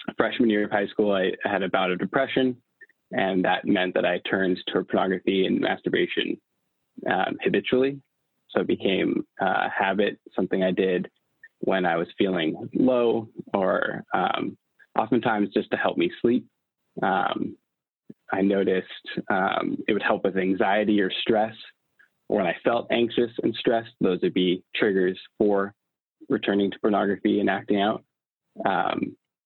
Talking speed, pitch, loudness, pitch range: 150 wpm, 105 Hz, -25 LUFS, 95-130 Hz